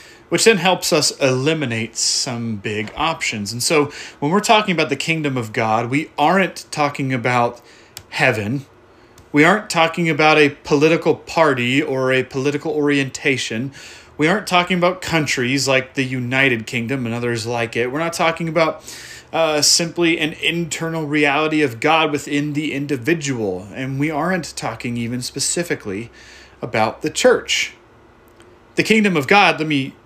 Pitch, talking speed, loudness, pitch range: 145 Hz, 150 wpm, -18 LUFS, 125-160 Hz